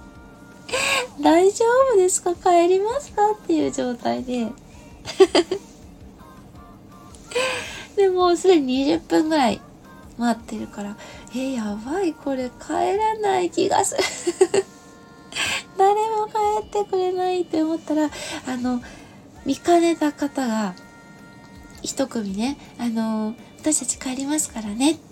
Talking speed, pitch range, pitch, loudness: 205 characters per minute, 255-380 Hz, 320 Hz, -22 LUFS